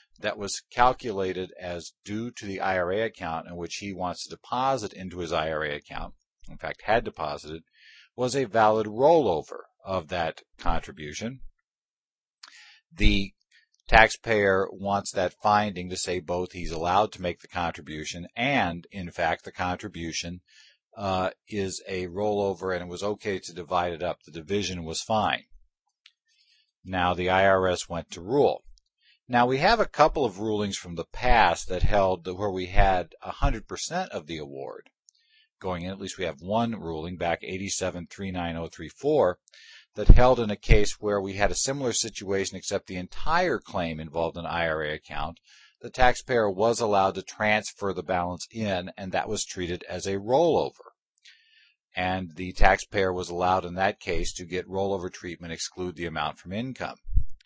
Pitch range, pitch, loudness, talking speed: 90-105 Hz, 95 Hz, -27 LUFS, 160 wpm